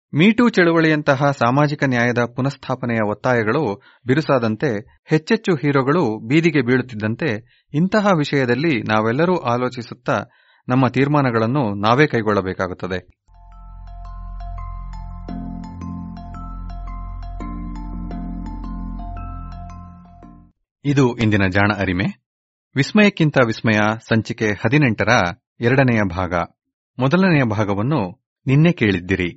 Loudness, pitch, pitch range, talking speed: -18 LUFS, 115 Hz, 90-140 Hz, 65 wpm